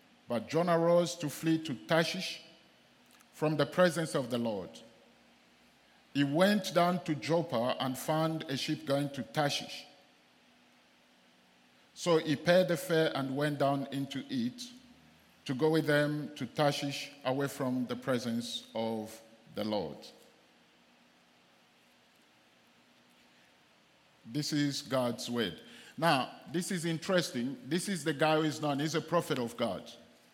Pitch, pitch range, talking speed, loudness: 150 Hz, 130-165 Hz, 135 wpm, -32 LUFS